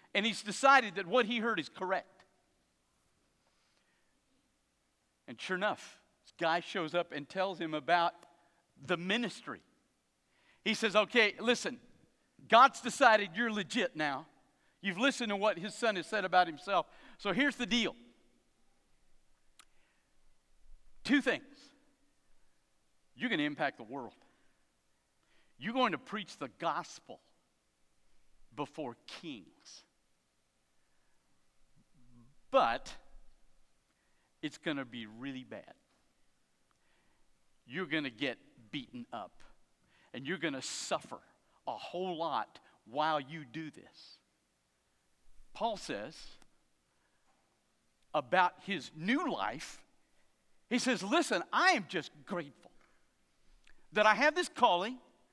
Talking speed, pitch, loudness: 110 wpm, 175 Hz, -33 LUFS